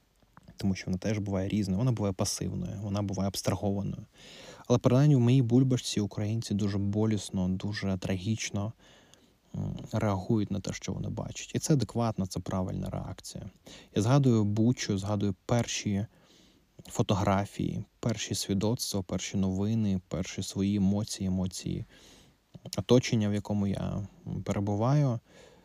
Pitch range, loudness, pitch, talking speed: 95-115 Hz, -30 LUFS, 105 Hz, 125 wpm